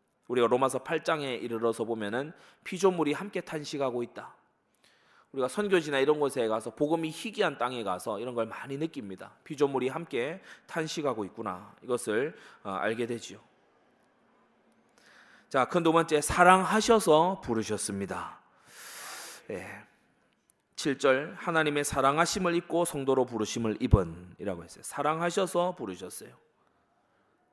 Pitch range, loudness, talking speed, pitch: 120-165 Hz, -29 LUFS, 290 characters per minute, 140 Hz